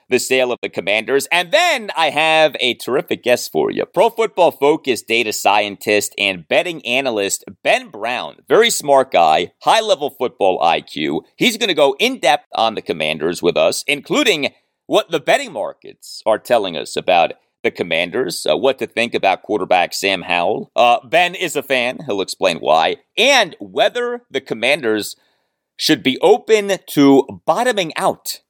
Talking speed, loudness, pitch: 165 wpm, -16 LUFS, 155 Hz